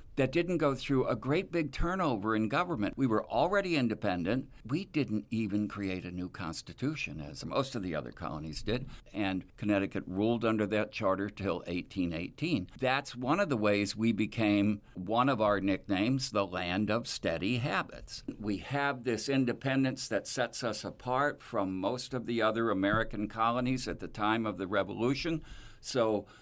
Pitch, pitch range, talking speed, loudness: 110 Hz, 100-130 Hz, 170 wpm, -32 LUFS